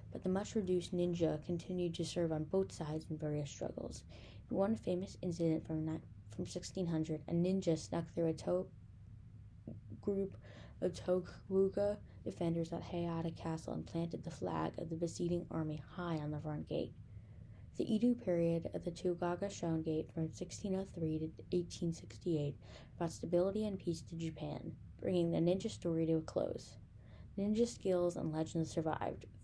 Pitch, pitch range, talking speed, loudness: 165 Hz, 155-180 Hz, 155 wpm, -39 LUFS